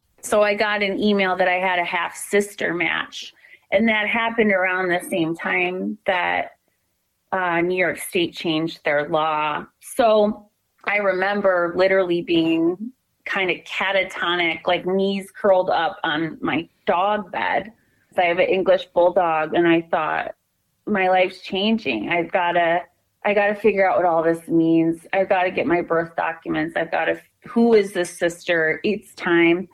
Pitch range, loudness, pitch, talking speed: 170-205 Hz, -20 LUFS, 185 Hz, 160 wpm